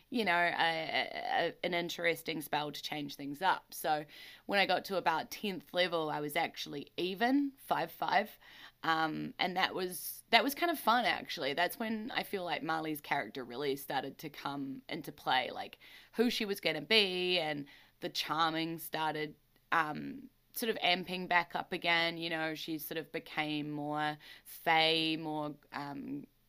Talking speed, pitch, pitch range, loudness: 175 wpm, 165 Hz, 150-185 Hz, -34 LUFS